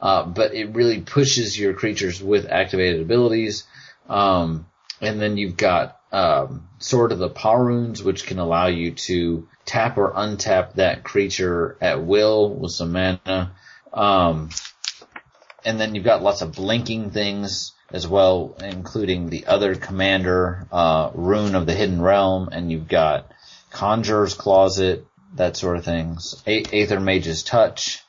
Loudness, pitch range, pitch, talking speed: -20 LUFS, 90-105 Hz, 95 Hz, 150 wpm